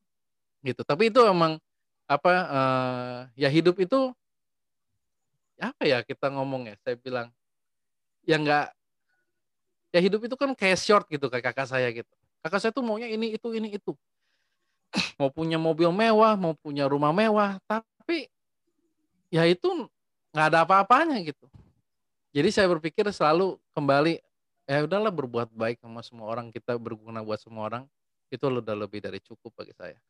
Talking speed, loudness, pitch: 150 wpm, -26 LUFS, 160 Hz